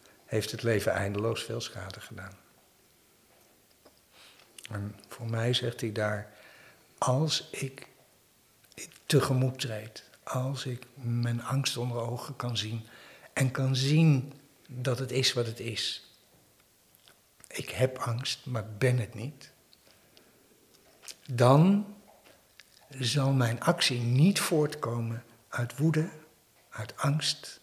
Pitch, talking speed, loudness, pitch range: 125 Hz, 110 wpm, -30 LUFS, 115-140 Hz